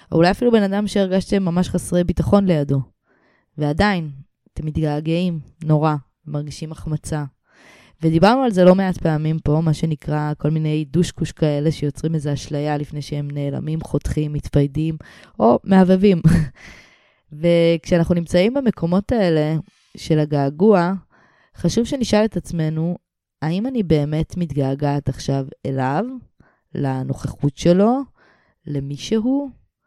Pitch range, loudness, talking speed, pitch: 145-180 Hz, -19 LUFS, 120 wpm, 160 Hz